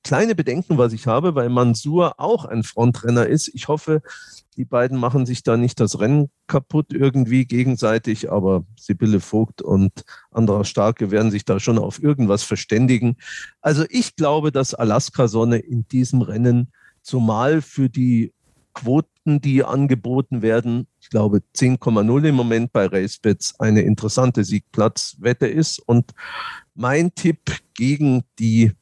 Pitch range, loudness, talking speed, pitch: 110-140 Hz, -19 LUFS, 145 wpm, 125 Hz